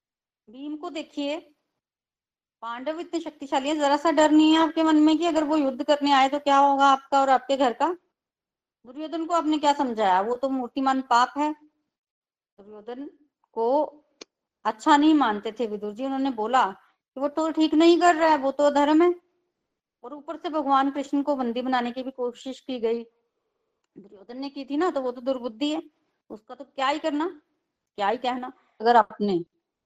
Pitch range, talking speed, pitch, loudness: 250-310 Hz, 190 wpm, 285 Hz, -23 LUFS